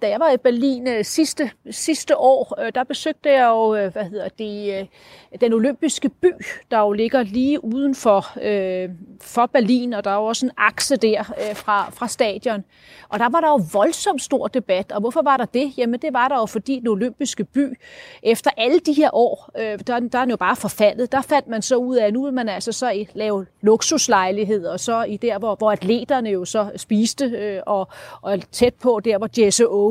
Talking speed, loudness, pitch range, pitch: 220 wpm, -20 LUFS, 210-270 Hz, 235 Hz